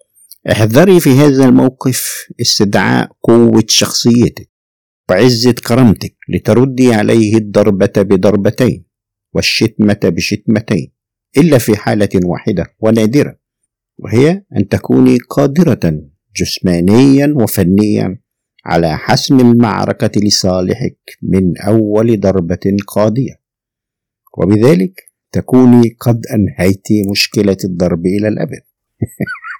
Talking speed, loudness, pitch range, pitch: 85 wpm, -11 LUFS, 100-125 Hz, 110 Hz